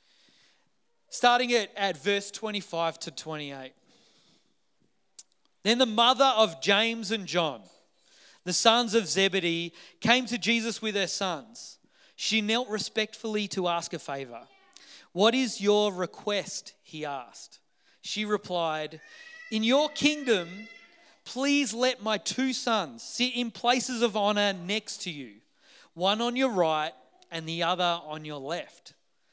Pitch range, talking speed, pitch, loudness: 175-240 Hz, 135 wpm, 210 Hz, -27 LUFS